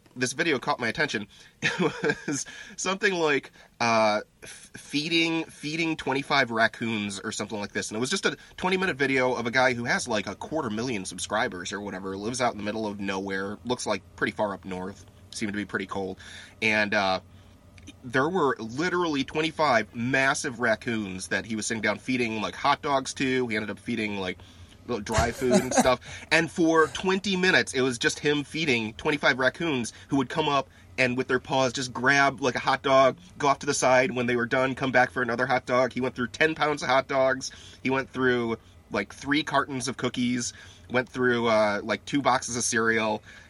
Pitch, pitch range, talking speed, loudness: 125 Hz, 105-140 Hz, 205 wpm, -26 LUFS